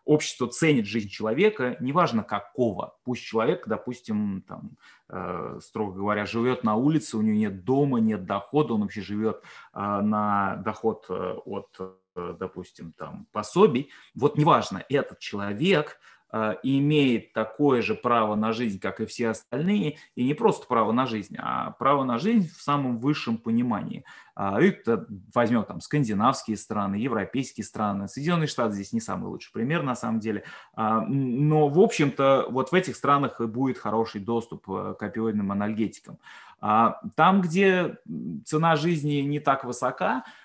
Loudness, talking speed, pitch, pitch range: -26 LUFS, 145 wpm, 115 Hz, 105-145 Hz